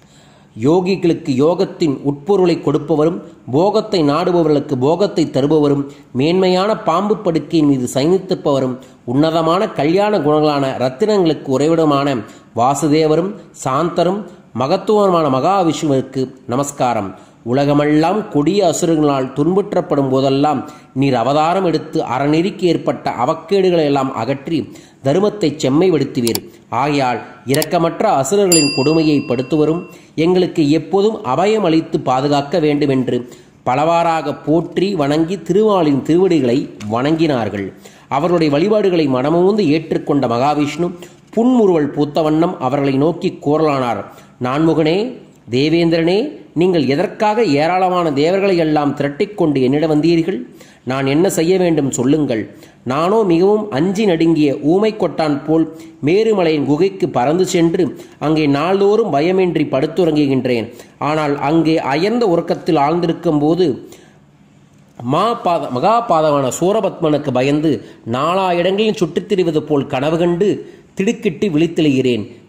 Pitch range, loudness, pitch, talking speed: 140-180 Hz, -15 LUFS, 160 Hz, 95 wpm